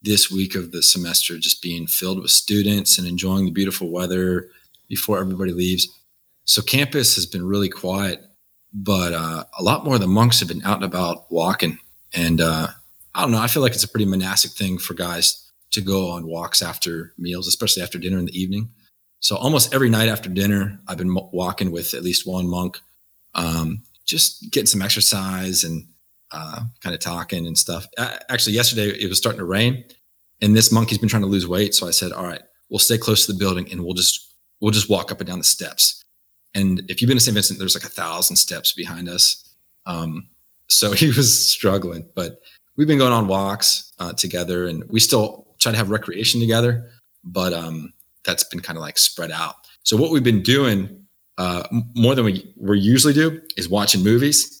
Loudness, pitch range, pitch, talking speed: -18 LUFS, 90-110 Hz, 95 Hz, 210 wpm